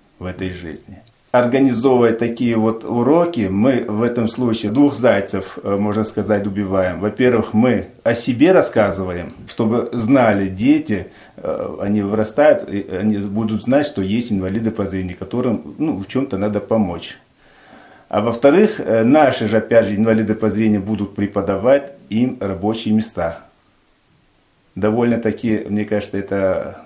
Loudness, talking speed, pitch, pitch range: -17 LUFS, 135 wpm, 110 Hz, 100-115 Hz